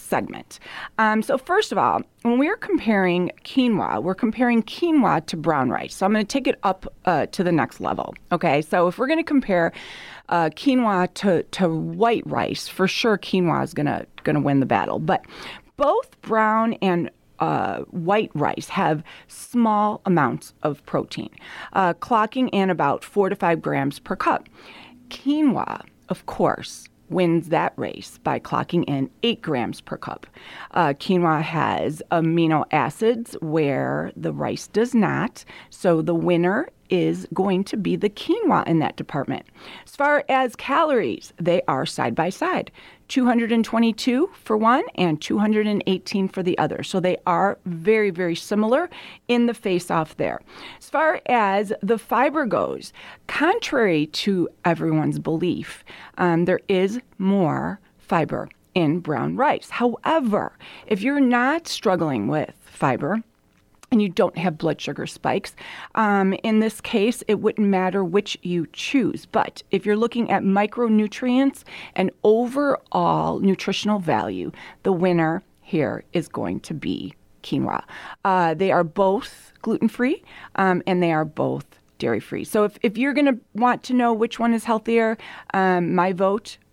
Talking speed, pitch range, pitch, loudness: 155 wpm, 175-235 Hz, 205 Hz, -22 LUFS